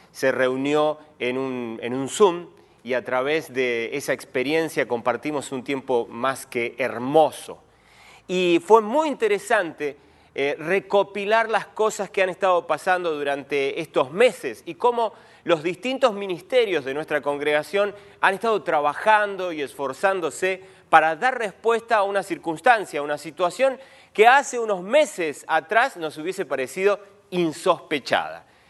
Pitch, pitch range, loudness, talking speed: 175 Hz, 145-205 Hz, -23 LUFS, 135 wpm